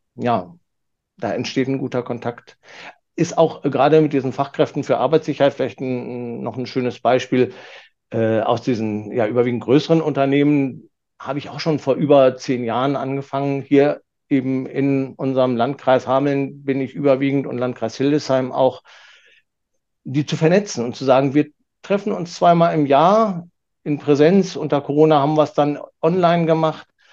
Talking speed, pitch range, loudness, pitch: 155 wpm, 130-150 Hz, -19 LUFS, 140 Hz